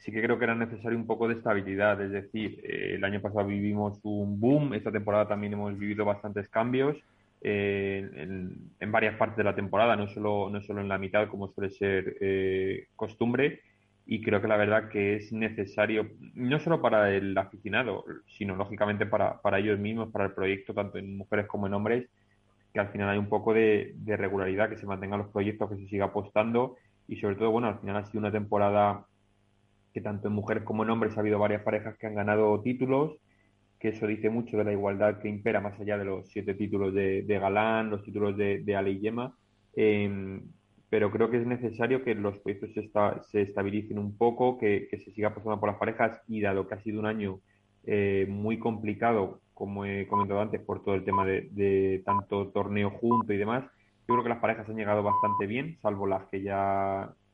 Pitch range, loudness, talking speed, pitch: 100-110 Hz, -30 LUFS, 210 wpm, 105 Hz